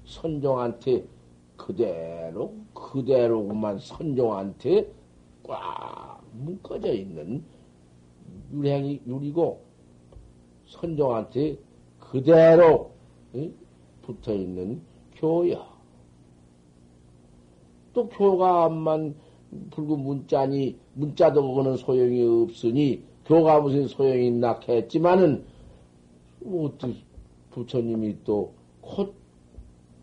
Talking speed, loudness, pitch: 165 characters per minute, -24 LUFS, 115 Hz